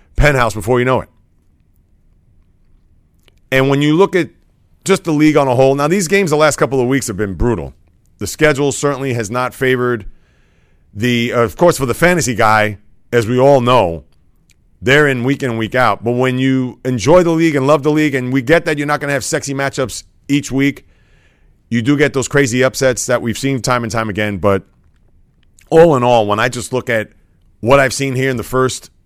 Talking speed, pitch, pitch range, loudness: 215 wpm, 125 Hz, 105-140 Hz, -14 LUFS